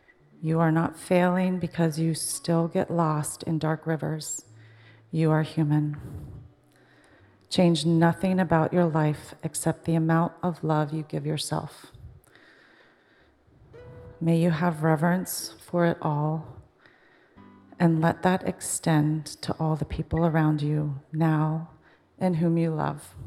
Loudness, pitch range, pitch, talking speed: -26 LUFS, 155-170 Hz, 160 Hz, 130 wpm